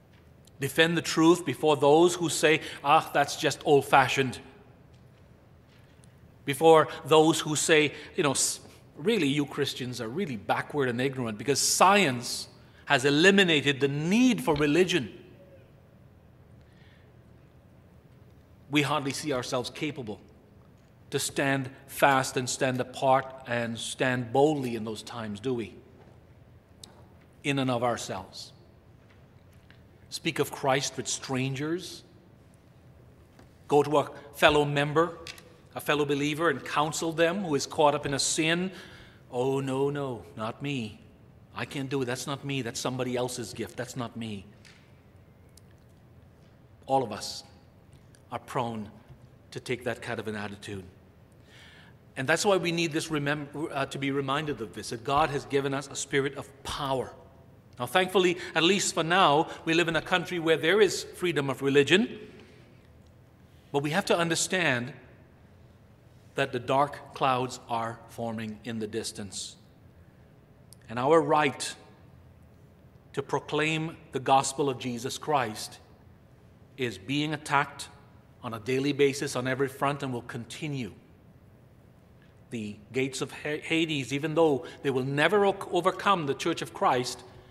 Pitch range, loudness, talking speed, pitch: 115-150 Hz, -27 LUFS, 140 wpm, 135 Hz